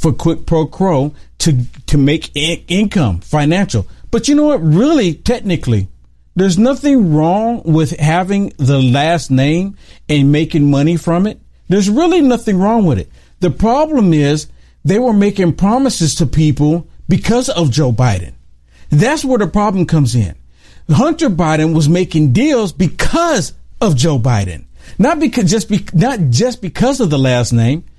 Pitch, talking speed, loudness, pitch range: 165 Hz, 160 wpm, -13 LUFS, 145-210 Hz